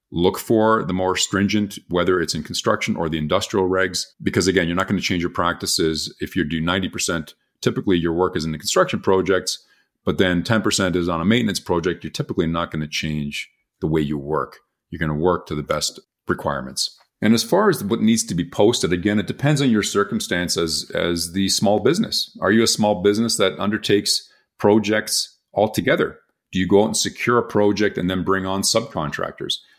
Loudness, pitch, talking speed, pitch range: -20 LUFS, 95 Hz, 205 wpm, 85-105 Hz